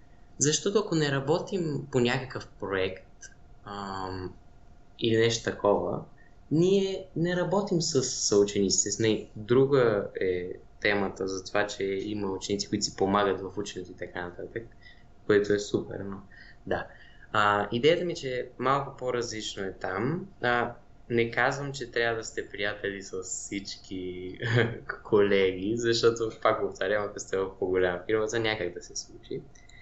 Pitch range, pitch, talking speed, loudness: 95-125 Hz, 110 Hz, 145 wpm, -28 LUFS